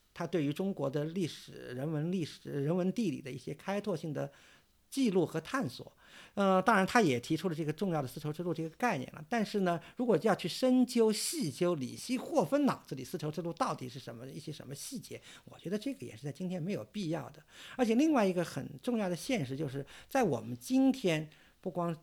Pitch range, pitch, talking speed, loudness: 150-210 Hz, 175 Hz, 325 characters per minute, -34 LUFS